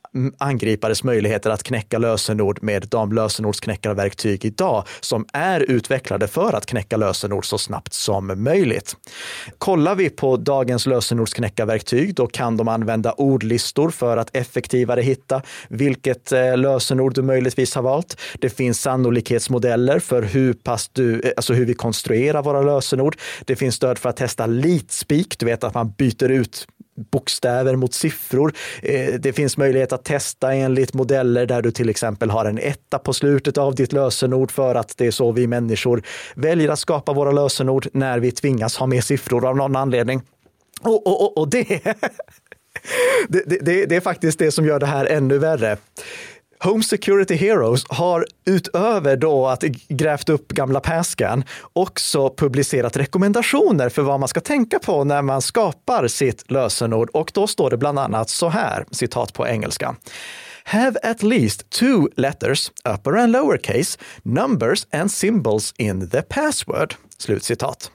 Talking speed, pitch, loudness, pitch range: 155 wpm, 130 Hz, -19 LUFS, 120-150 Hz